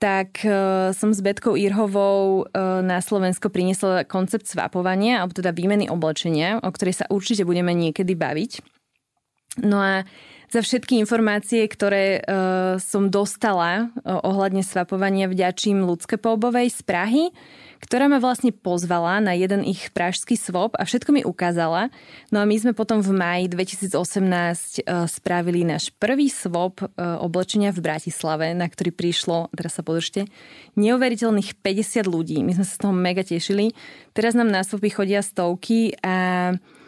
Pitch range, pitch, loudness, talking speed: 180-215 Hz, 195 Hz, -22 LUFS, 150 wpm